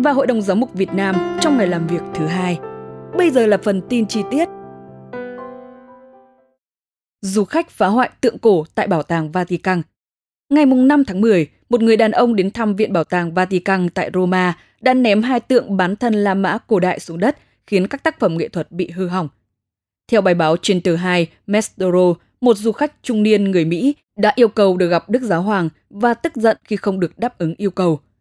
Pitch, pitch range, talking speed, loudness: 195 Hz, 175-235 Hz, 215 wpm, -17 LUFS